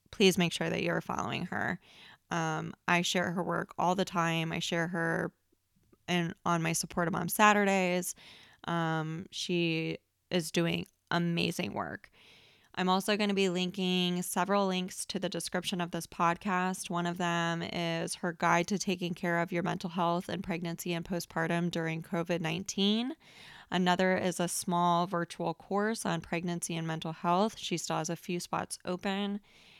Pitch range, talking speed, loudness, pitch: 170-185 Hz, 165 wpm, -32 LUFS, 175 Hz